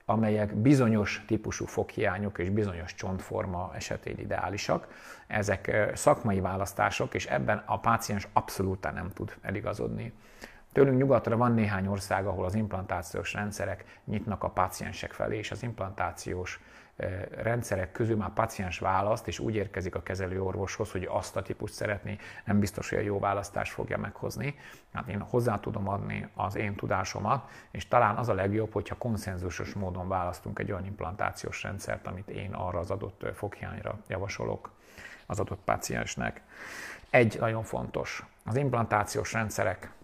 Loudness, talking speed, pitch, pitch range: -31 LUFS, 145 wpm, 105 Hz, 95-110 Hz